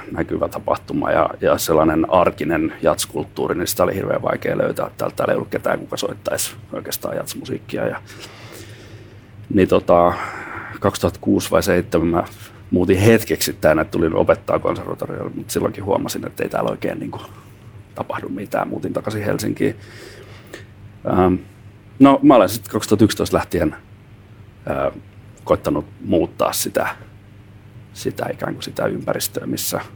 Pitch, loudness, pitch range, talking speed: 105 Hz, -19 LUFS, 100-110 Hz, 135 wpm